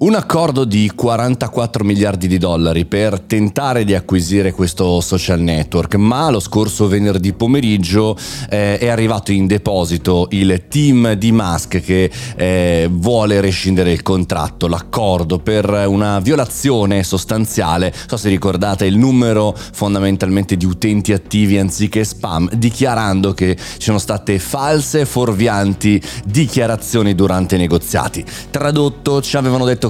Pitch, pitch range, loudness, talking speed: 105 Hz, 95-115 Hz, -15 LUFS, 130 wpm